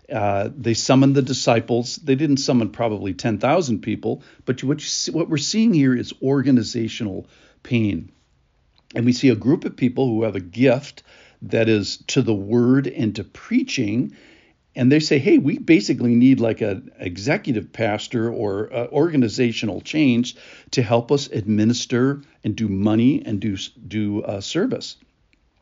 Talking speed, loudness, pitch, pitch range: 155 wpm, -20 LUFS, 120 Hz, 110-135 Hz